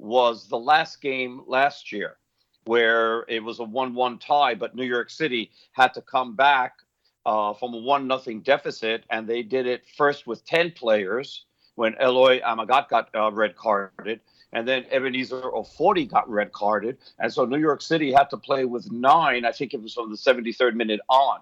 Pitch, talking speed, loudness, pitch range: 125 Hz, 185 wpm, -23 LUFS, 115-135 Hz